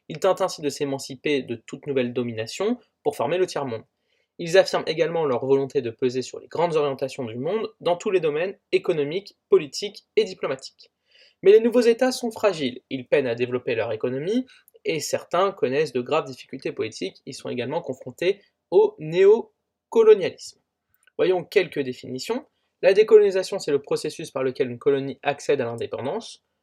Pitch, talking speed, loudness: 205 Hz, 165 wpm, -23 LUFS